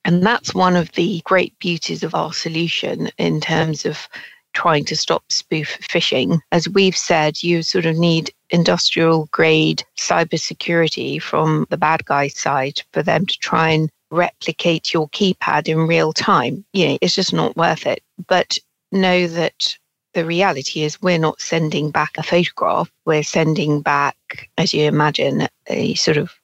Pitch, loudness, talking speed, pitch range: 165 Hz, -18 LUFS, 165 wpm, 155-175 Hz